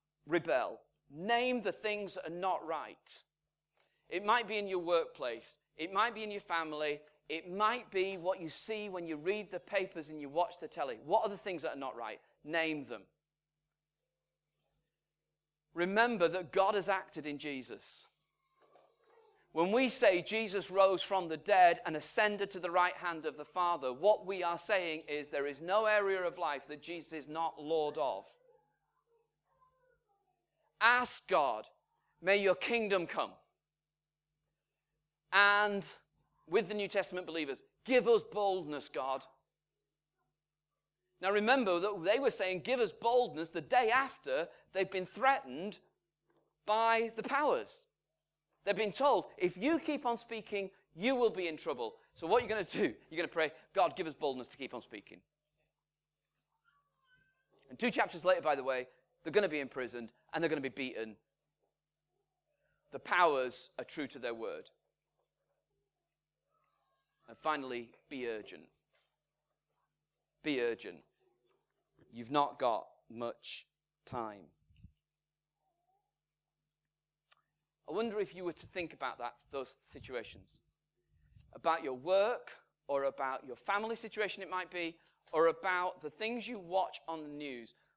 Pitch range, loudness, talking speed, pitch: 150-215 Hz, -35 LUFS, 150 wpm, 175 Hz